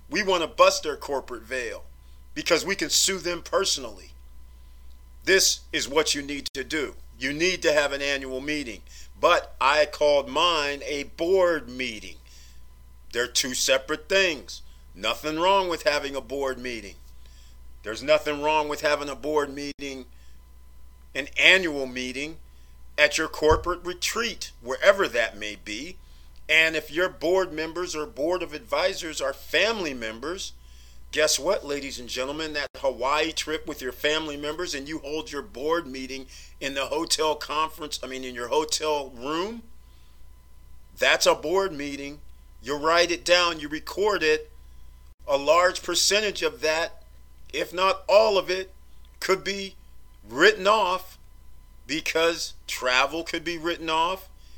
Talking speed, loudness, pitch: 150 wpm, -24 LUFS, 145 Hz